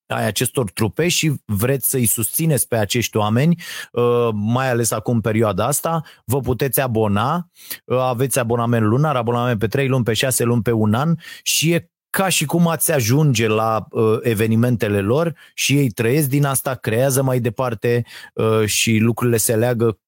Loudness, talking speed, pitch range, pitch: -18 LUFS, 165 wpm, 115-140 Hz, 120 Hz